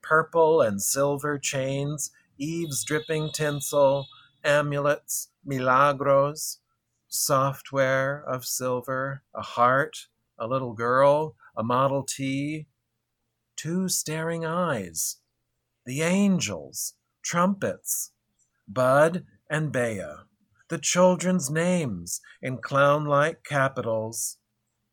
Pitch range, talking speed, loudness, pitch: 125-155 Hz, 85 wpm, -25 LUFS, 140 Hz